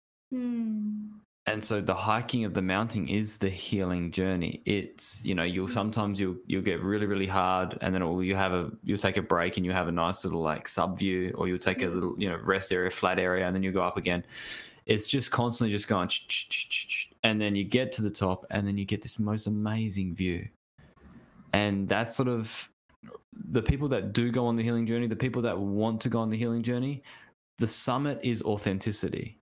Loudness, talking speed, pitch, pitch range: -29 LUFS, 215 wpm, 105 Hz, 95-115 Hz